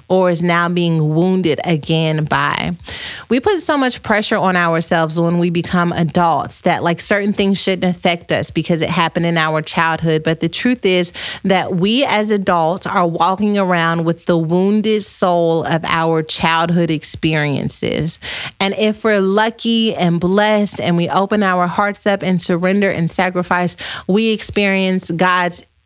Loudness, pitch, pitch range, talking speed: -15 LUFS, 180 Hz, 165-195 Hz, 160 wpm